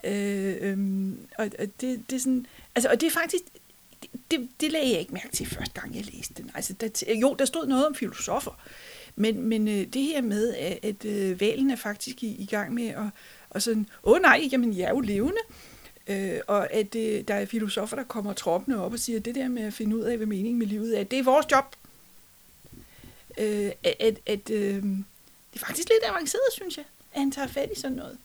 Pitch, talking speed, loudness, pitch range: 230 Hz, 220 wpm, -27 LUFS, 210-270 Hz